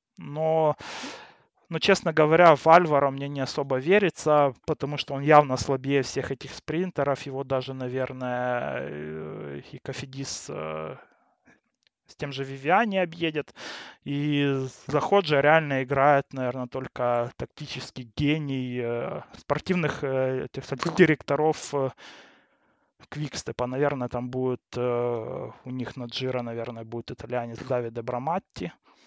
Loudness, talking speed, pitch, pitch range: -26 LUFS, 115 wpm, 135 Hz, 125-150 Hz